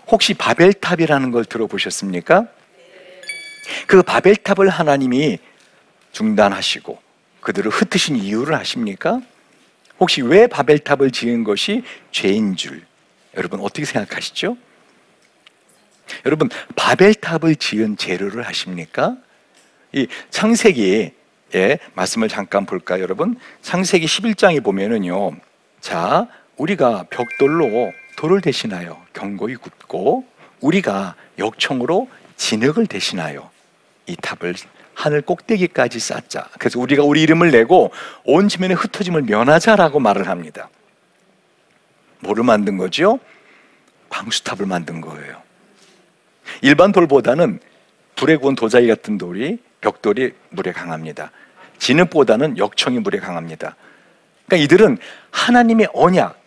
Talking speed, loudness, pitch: 270 characters per minute, -16 LUFS, 160 Hz